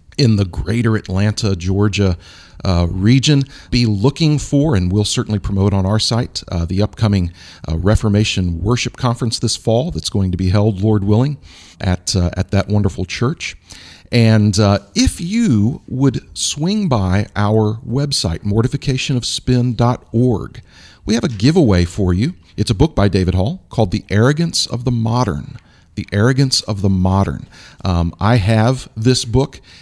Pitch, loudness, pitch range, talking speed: 105 Hz, -16 LUFS, 95-125 Hz, 155 wpm